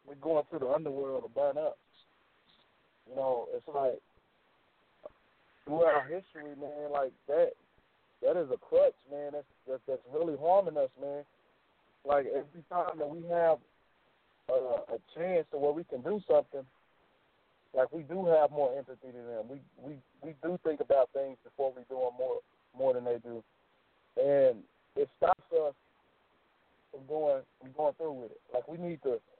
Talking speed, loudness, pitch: 170 wpm, -33 LUFS, 160 Hz